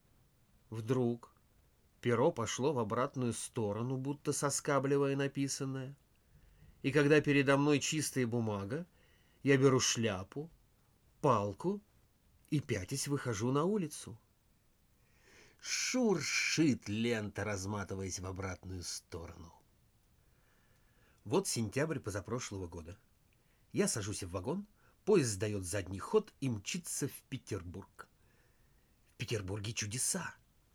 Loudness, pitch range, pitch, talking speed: -35 LUFS, 100-140 Hz, 120 Hz, 95 wpm